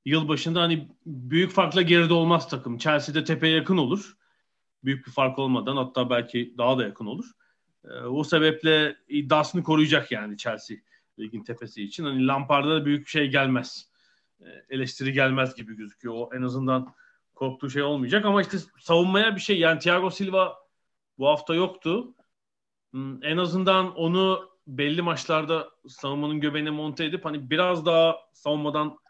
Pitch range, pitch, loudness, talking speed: 135-175 Hz, 155 Hz, -24 LUFS, 155 wpm